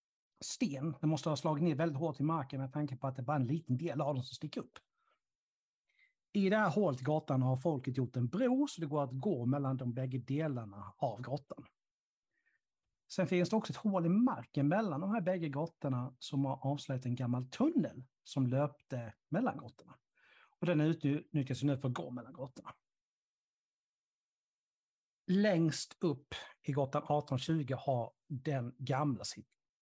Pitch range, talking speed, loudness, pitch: 130-165 Hz, 175 wpm, -36 LUFS, 145 Hz